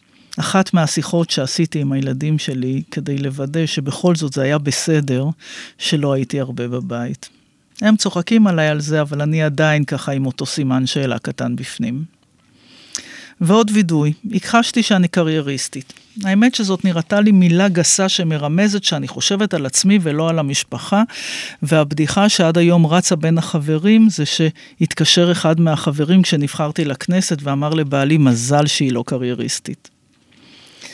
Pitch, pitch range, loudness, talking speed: 155 Hz, 140-185 Hz, -16 LUFS, 135 wpm